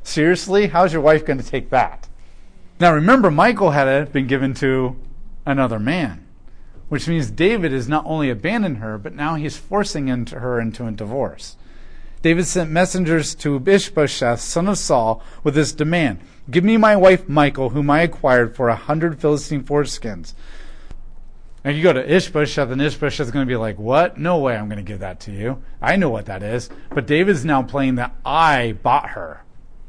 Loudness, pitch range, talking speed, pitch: -18 LUFS, 125-165 Hz, 185 wpm, 145 Hz